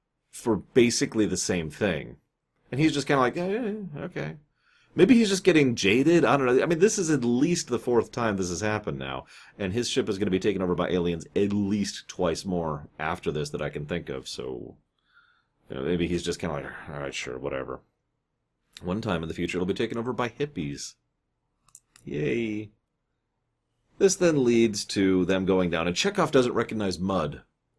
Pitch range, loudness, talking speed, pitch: 90-140 Hz, -26 LUFS, 200 wpm, 105 Hz